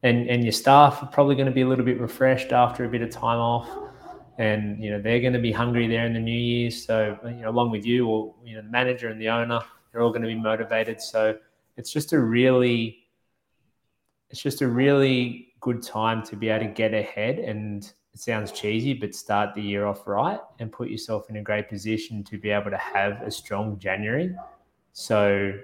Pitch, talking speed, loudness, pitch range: 115 Hz, 220 wpm, -24 LUFS, 110-125 Hz